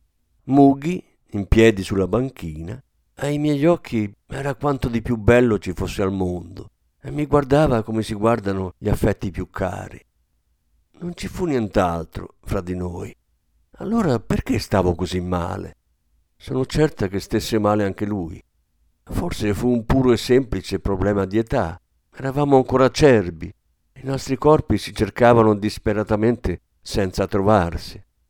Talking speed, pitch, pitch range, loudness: 140 wpm, 105 Hz, 90-125 Hz, -20 LUFS